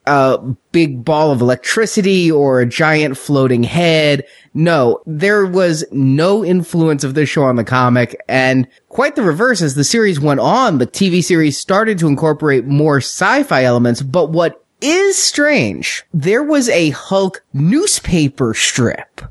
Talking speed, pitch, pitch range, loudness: 150 wpm, 155 Hz, 135-180 Hz, -13 LUFS